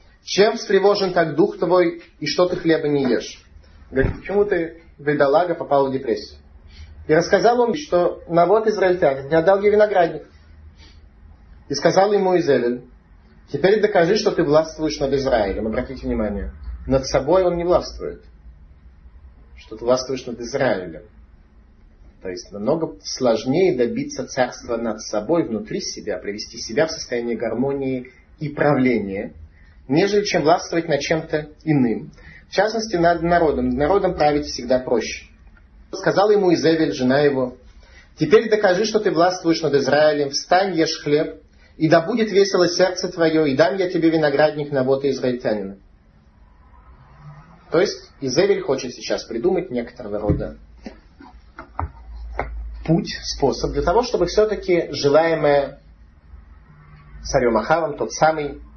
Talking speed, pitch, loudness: 135 wpm, 145 Hz, -19 LUFS